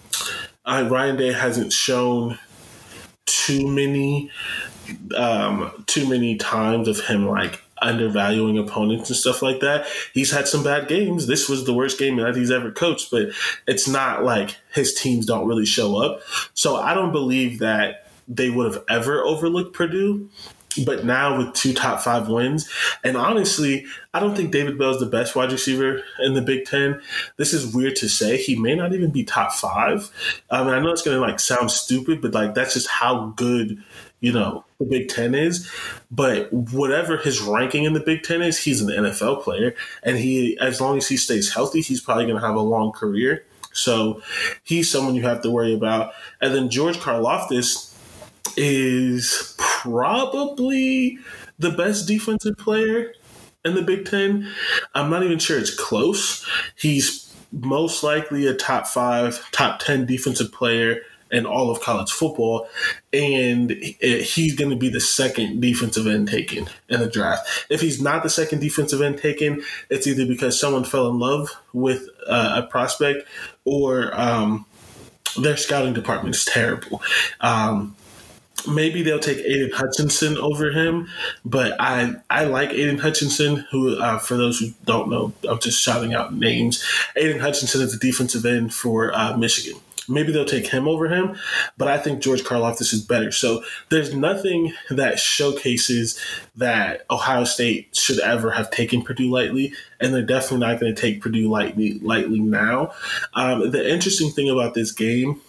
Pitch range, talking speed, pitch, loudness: 120-150 Hz, 170 wpm, 130 Hz, -21 LUFS